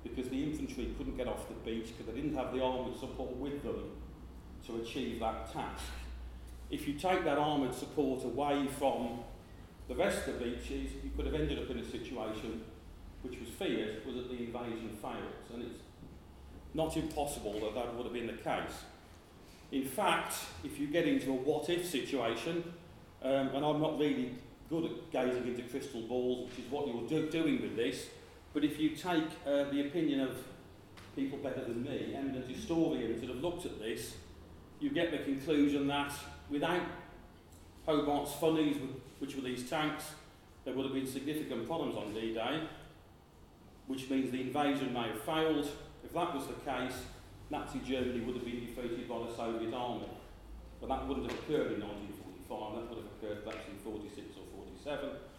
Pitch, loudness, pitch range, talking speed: 130 Hz, -37 LUFS, 115-145 Hz, 180 wpm